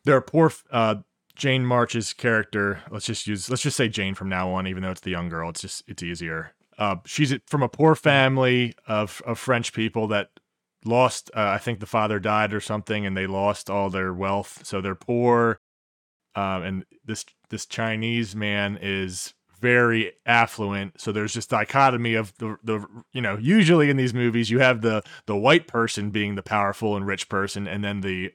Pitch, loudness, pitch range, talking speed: 110 Hz, -23 LUFS, 100-120 Hz, 195 wpm